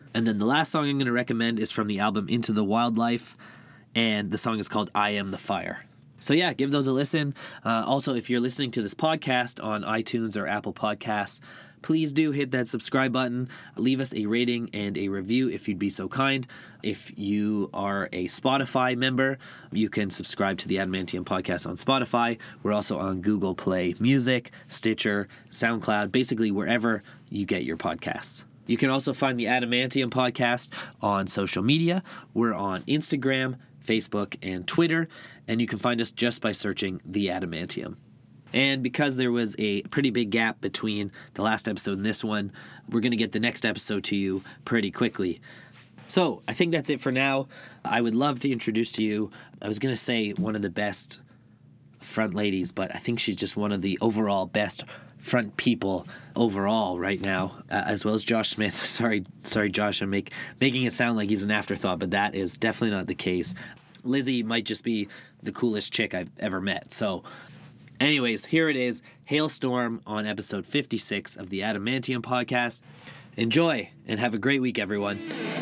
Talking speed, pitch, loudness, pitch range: 190 wpm, 115 Hz, -26 LUFS, 105-130 Hz